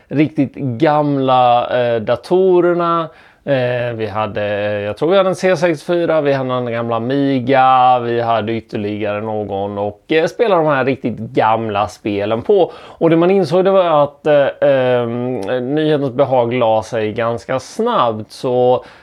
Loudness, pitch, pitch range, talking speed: -15 LUFS, 125 Hz, 110-150 Hz, 150 wpm